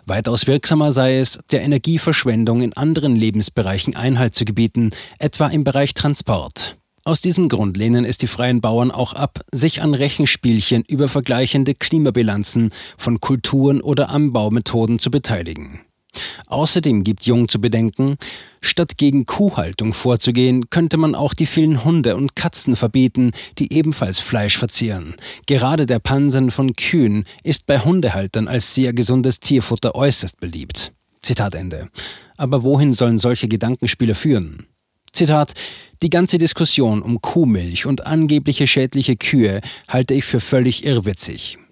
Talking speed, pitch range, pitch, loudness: 140 wpm, 115-145 Hz, 125 Hz, -17 LUFS